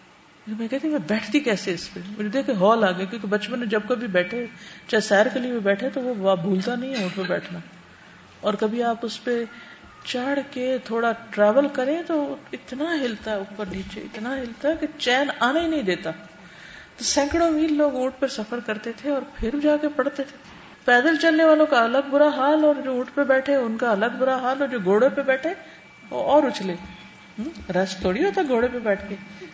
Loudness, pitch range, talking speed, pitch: -23 LUFS, 210-280 Hz, 140 wpm, 245 Hz